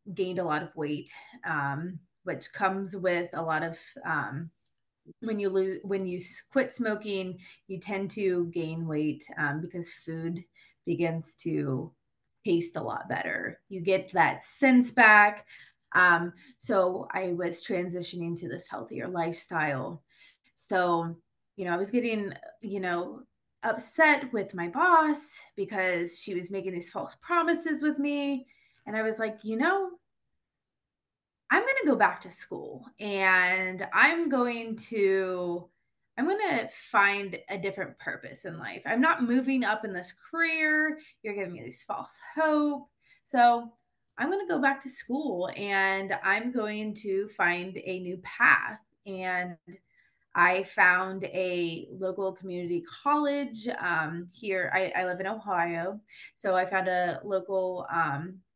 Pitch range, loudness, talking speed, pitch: 175-235 Hz, -28 LUFS, 145 wpm, 190 Hz